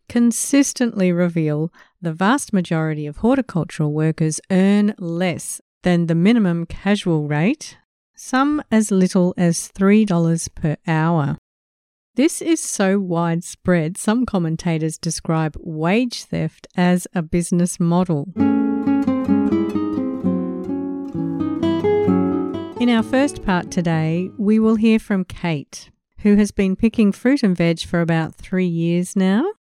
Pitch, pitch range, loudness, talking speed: 180 Hz, 165-225 Hz, -19 LUFS, 115 wpm